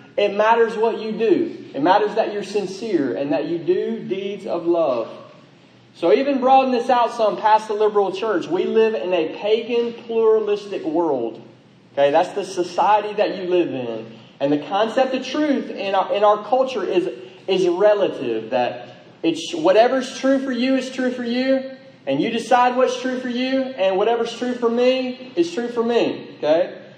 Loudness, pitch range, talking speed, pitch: -20 LUFS, 195-255 Hz, 180 wpm, 230 Hz